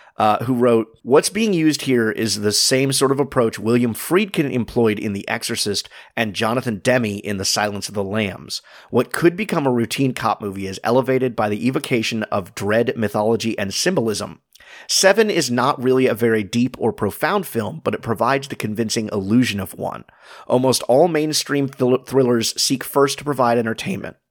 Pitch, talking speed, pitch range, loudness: 120 Hz, 180 wpm, 110-135 Hz, -19 LUFS